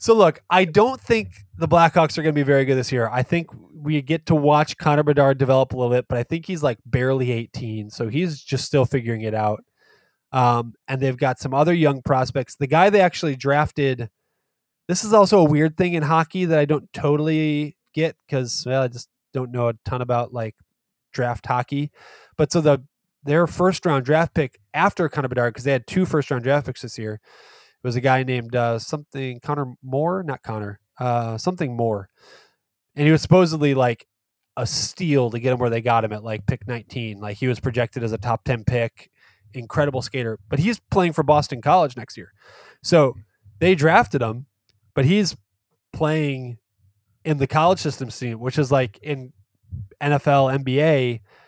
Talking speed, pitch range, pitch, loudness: 190 wpm, 120-155 Hz, 135 Hz, -21 LUFS